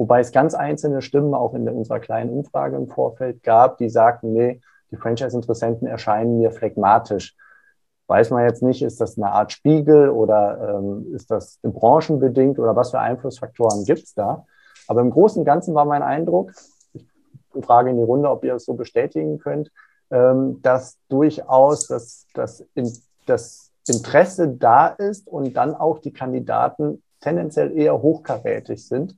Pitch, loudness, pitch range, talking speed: 130 Hz, -19 LUFS, 115-145 Hz, 165 wpm